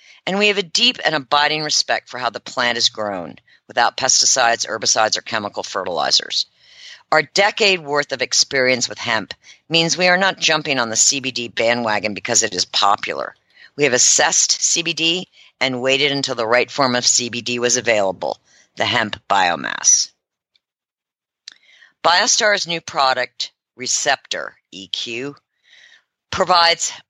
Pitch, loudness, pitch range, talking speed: 140 Hz, -16 LUFS, 120-170 Hz, 140 wpm